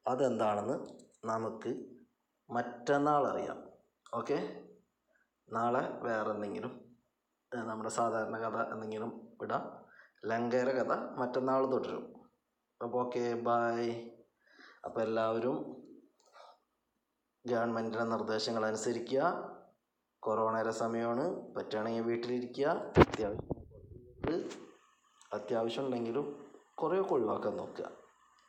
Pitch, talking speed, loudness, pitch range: 115 Hz, 75 wpm, -35 LUFS, 110-125 Hz